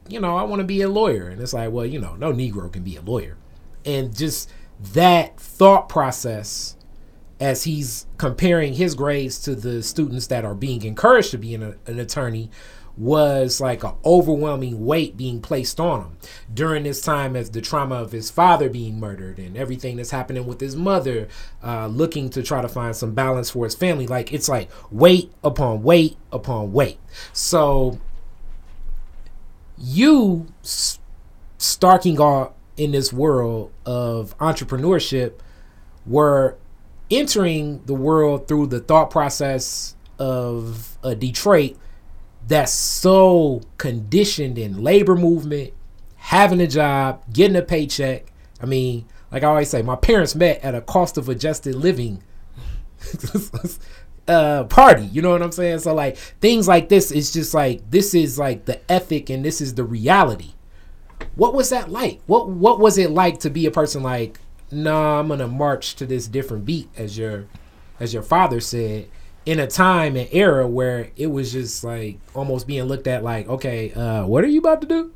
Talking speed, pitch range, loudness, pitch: 170 wpm, 115-155 Hz, -19 LUFS, 135 Hz